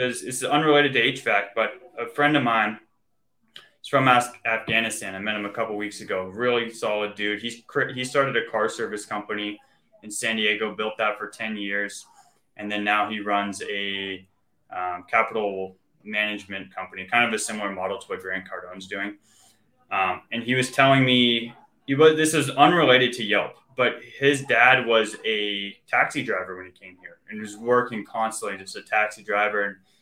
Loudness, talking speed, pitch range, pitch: -23 LUFS, 170 wpm, 100-120 Hz, 105 Hz